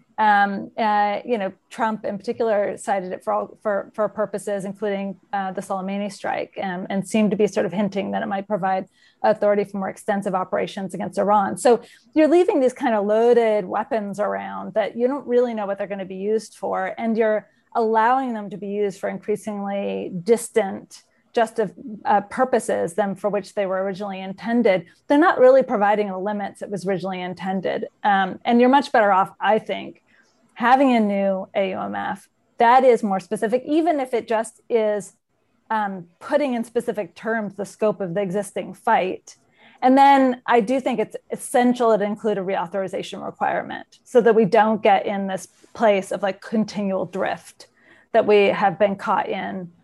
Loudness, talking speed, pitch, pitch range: -21 LUFS, 185 wpm, 210 Hz, 195-230 Hz